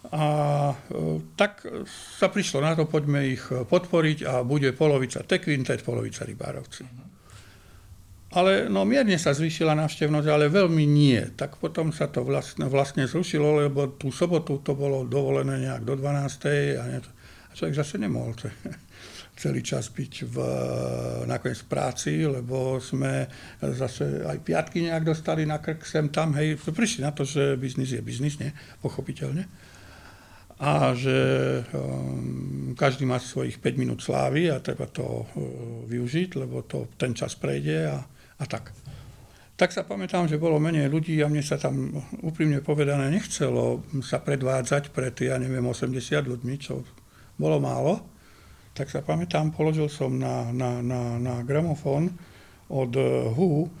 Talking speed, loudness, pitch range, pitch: 150 wpm, -26 LUFS, 120-155 Hz, 135 Hz